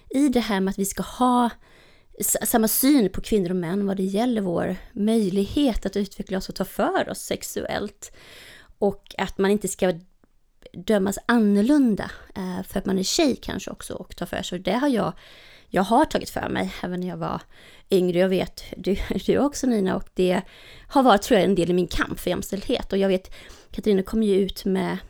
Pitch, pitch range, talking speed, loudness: 195 Hz, 190-225 Hz, 205 wpm, -23 LUFS